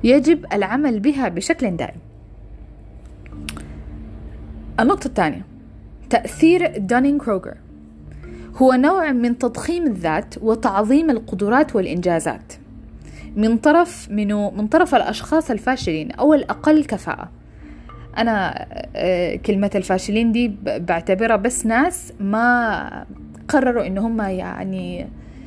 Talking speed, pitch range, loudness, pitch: 90 wpm, 190-270 Hz, -19 LUFS, 225 Hz